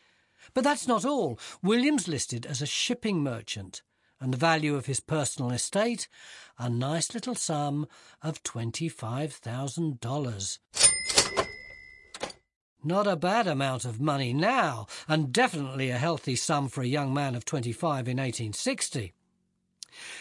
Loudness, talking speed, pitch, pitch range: -28 LUFS, 135 wpm, 145 Hz, 125-165 Hz